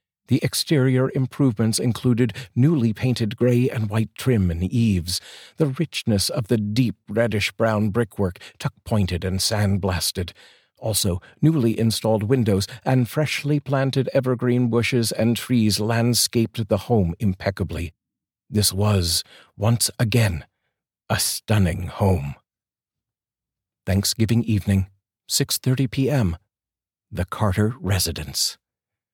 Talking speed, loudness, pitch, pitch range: 105 wpm, -22 LUFS, 110 Hz, 100-125 Hz